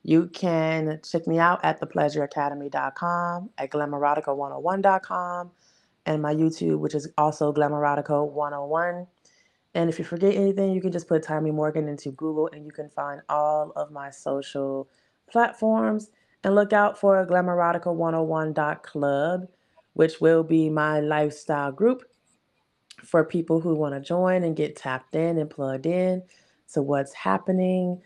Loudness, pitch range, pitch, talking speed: -25 LUFS, 150-180 Hz, 160 Hz, 140 wpm